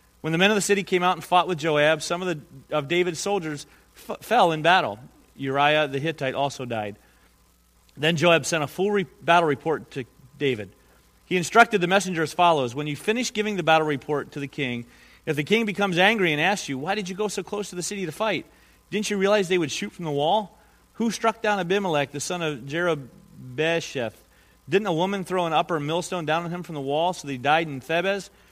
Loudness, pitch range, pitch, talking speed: -24 LUFS, 145-195 Hz, 165 Hz, 225 wpm